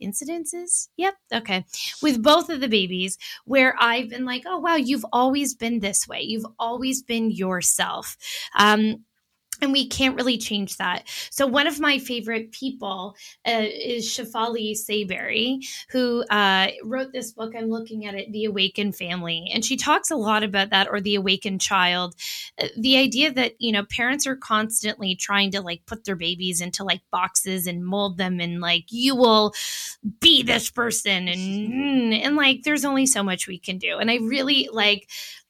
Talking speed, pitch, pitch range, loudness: 175 wpm, 225 Hz, 195-260 Hz, -22 LUFS